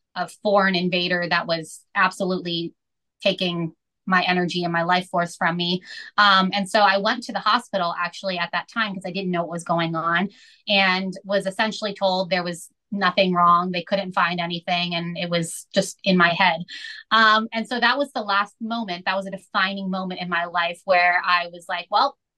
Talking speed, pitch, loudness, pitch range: 200 wpm, 185 Hz, -22 LUFS, 175-200 Hz